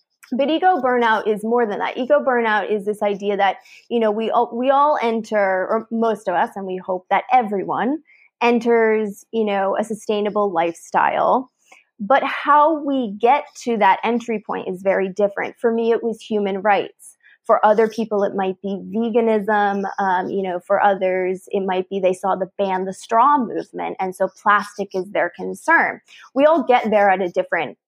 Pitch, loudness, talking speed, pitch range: 210 Hz, -19 LUFS, 185 wpm, 195-235 Hz